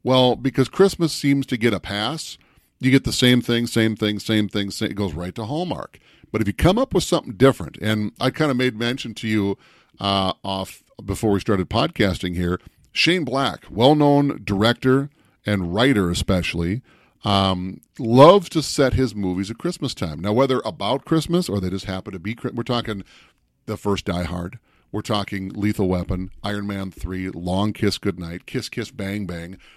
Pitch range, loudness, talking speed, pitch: 95-130 Hz, -21 LUFS, 185 wpm, 105 Hz